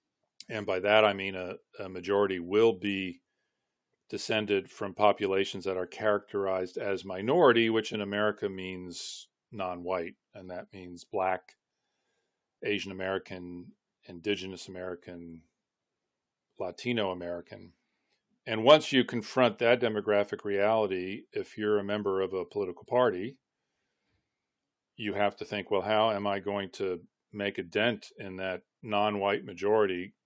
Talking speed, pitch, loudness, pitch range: 135 wpm, 100 Hz, -30 LUFS, 95-105 Hz